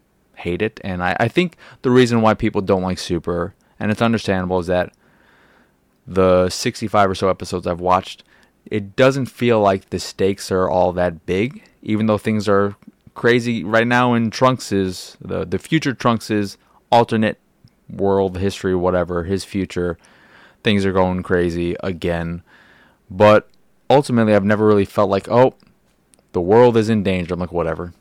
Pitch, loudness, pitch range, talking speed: 100 Hz, -18 LUFS, 90-110 Hz, 165 wpm